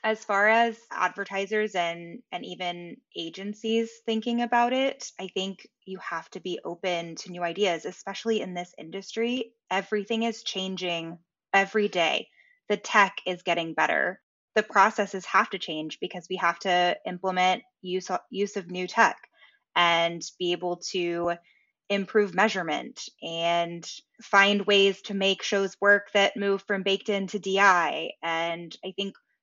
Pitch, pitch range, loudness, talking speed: 195 Hz, 175-210 Hz, -26 LUFS, 150 wpm